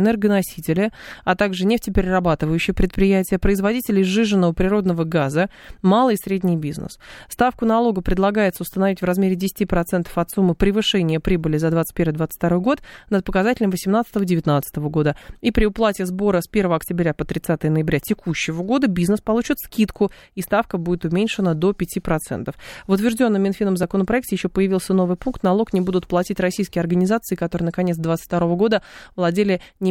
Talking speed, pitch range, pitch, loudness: 145 wpm, 175-205 Hz, 190 Hz, -20 LUFS